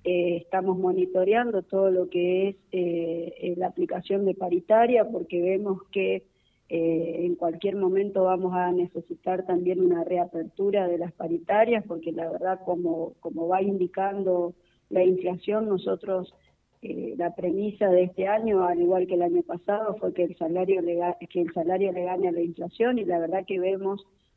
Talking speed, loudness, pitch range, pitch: 165 wpm, -26 LUFS, 175-195 Hz, 180 Hz